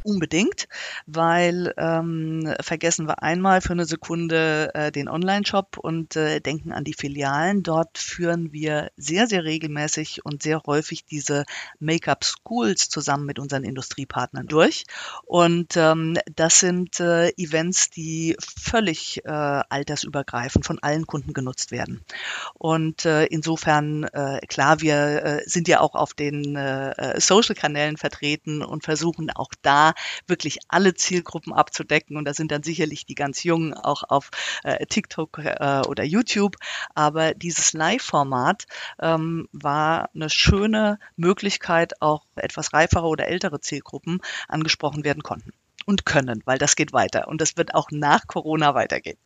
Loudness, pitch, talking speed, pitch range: -22 LUFS, 160 Hz, 145 wpm, 150-170 Hz